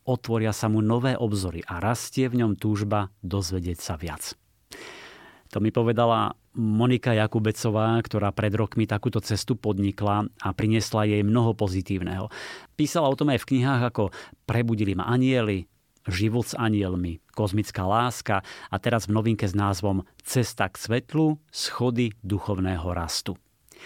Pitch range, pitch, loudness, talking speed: 100-120 Hz, 110 Hz, -26 LUFS, 140 wpm